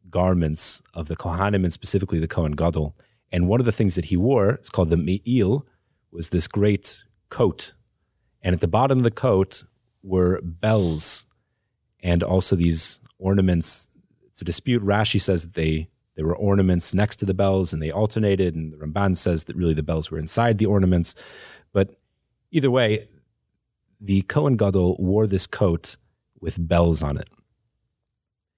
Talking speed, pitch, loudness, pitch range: 170 wpm, 95 Hz, -22 LUFS, 85-105 Hz